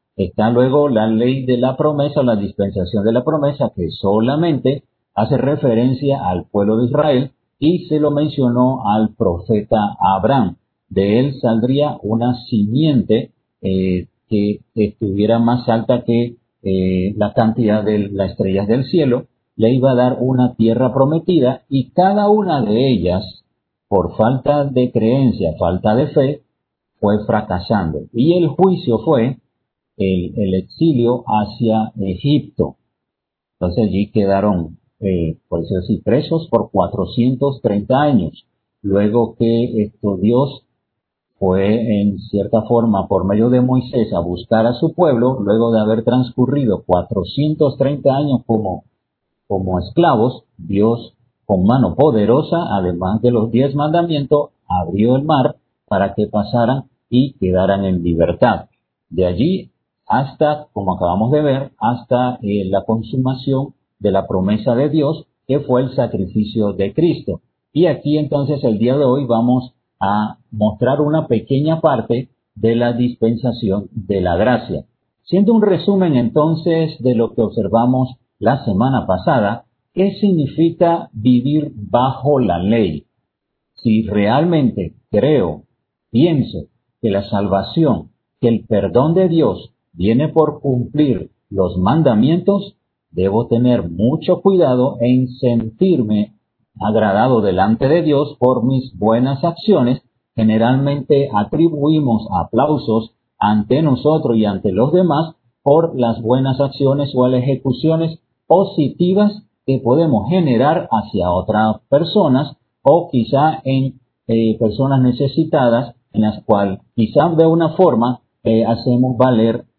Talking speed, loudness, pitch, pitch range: 130 wpm, -16 LUFS, 120 Hz, 105-140 Hz